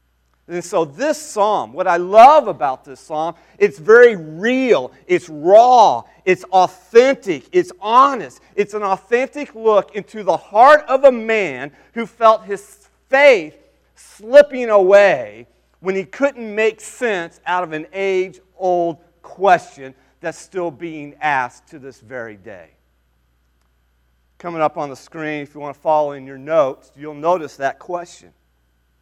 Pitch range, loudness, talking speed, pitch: 140-220 Hz, -15 LUFS, 145 wpm, 175 Hz